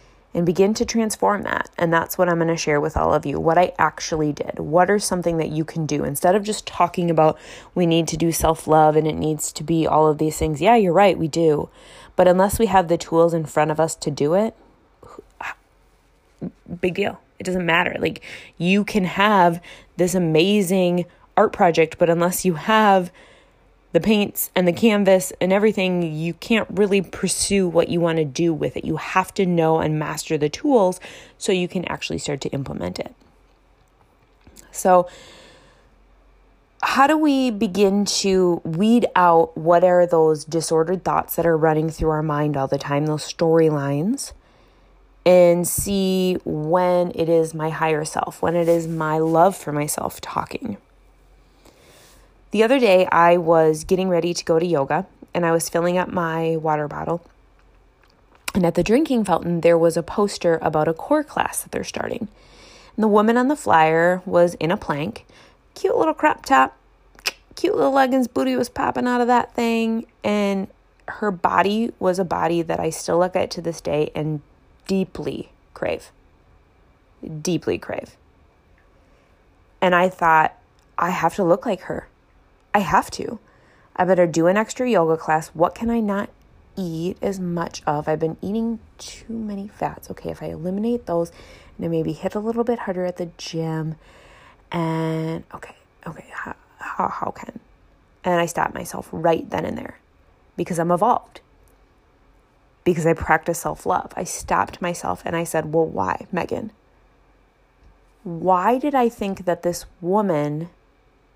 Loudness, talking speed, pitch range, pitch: -20 LUFS, 170 wpm, 160-195 Hz, 175 Hz